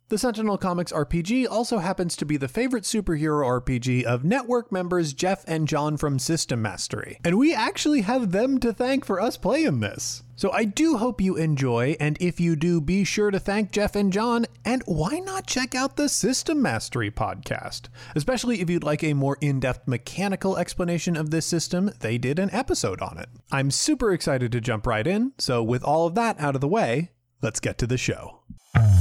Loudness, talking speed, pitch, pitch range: -24 LUFS, 205 wpm, 170 Hz, 135-215 Hz